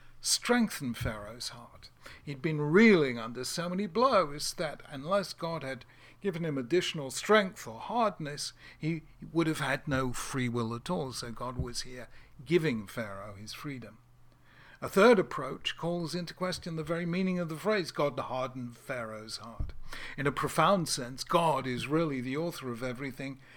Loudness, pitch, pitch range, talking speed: -31 LUFS, 145 Hz, 125-170 Hz, 165 wpm